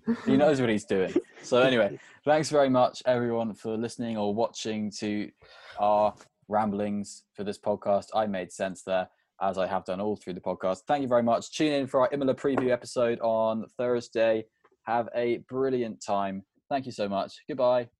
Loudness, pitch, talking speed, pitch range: -28 LUFS, 110 Hz, 185 wpm, 105-125 Hz